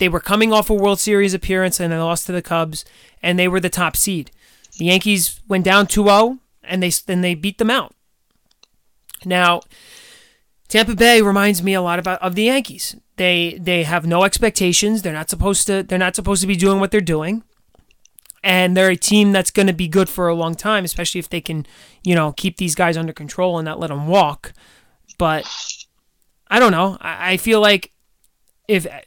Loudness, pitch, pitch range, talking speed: -17 LUFS, 185 Hz, 175-200 Hz, 205 wpm